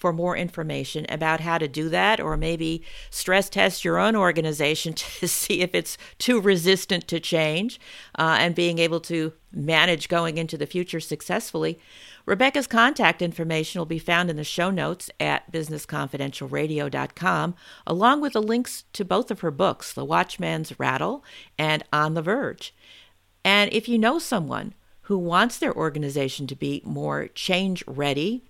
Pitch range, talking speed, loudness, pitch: 155-195 Hz, 160 wpm, -24 LUFS, 170 Hz